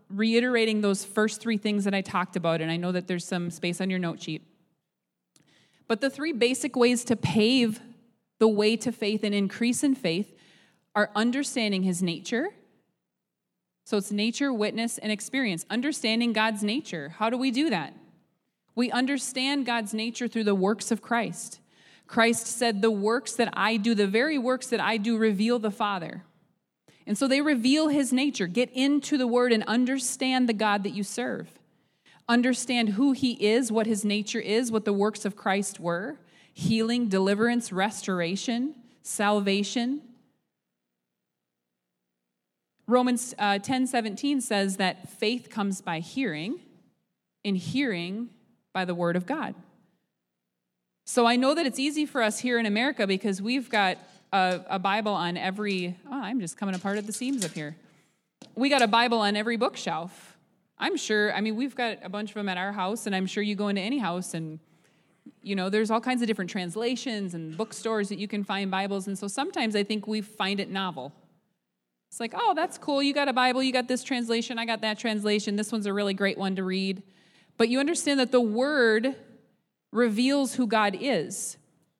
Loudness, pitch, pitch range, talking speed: -27 LUFS, 215 Hz, 190-245 Hz, 180 wpm